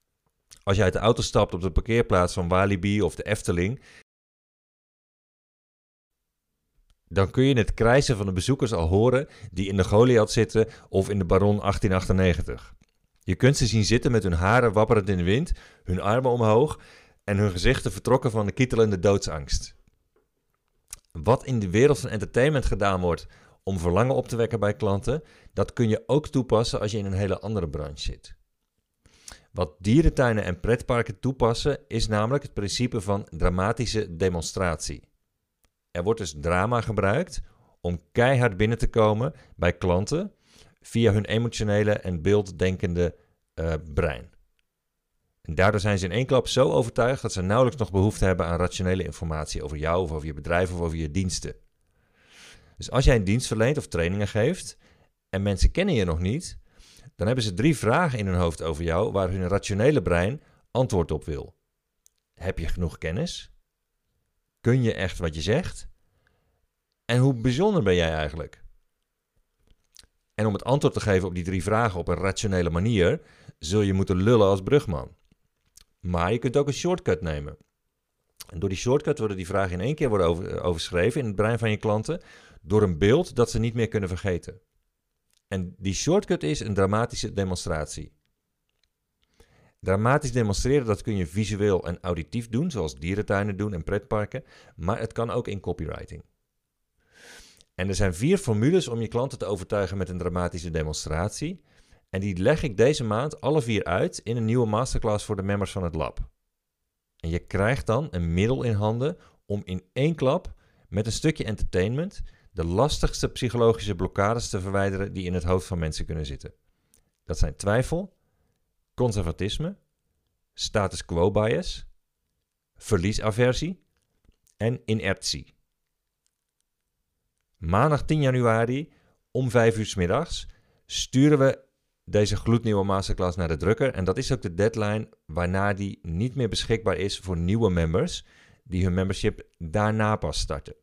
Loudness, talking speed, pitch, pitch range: -25 LUFS, 165 wpm, 100 Hz, 90-115 Hz